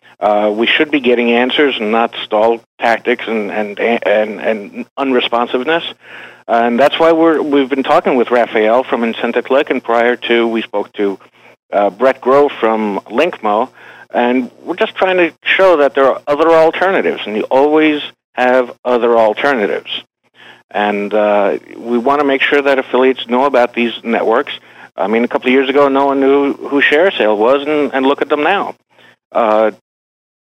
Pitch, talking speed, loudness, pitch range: 125 Hz, 175 wpm, -13 LUFS, 115-140 Hz